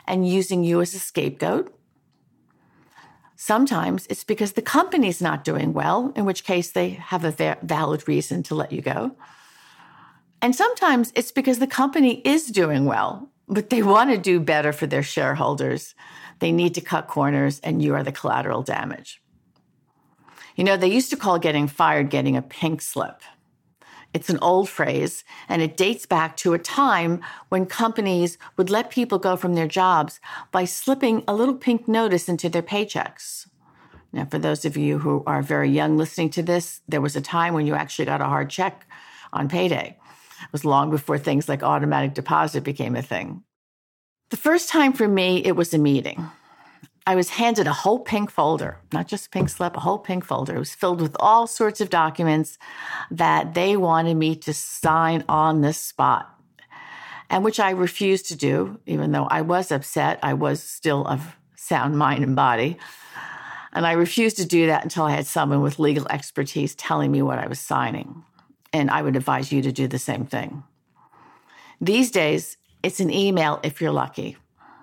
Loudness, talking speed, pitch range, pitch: -22 LUFS, 185 wpm, 155-210 Hz, 175 Hz